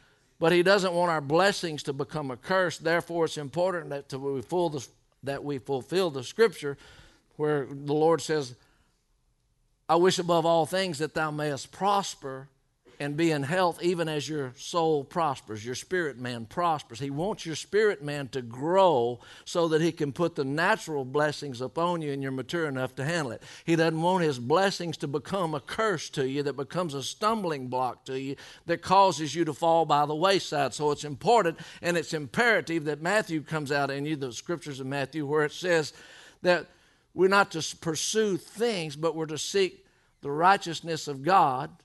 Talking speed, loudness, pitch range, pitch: 180 wpm, -28 LUFS, 140-175 Hz, 155 Hz